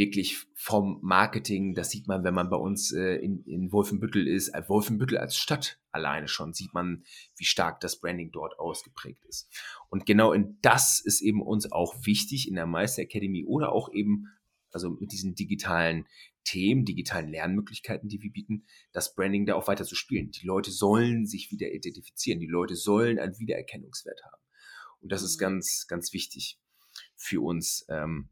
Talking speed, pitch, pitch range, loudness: 180 wpm, 100 Hz, 90-105 Hz, -29 LUFS